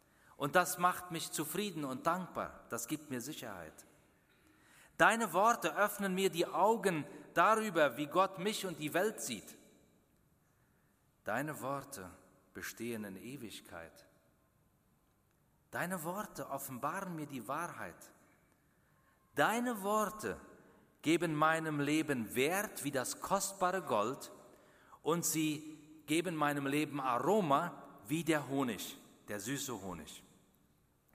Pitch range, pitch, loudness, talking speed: 140-180 Hz, 155 Hz, -36 LUFS, 110 wpm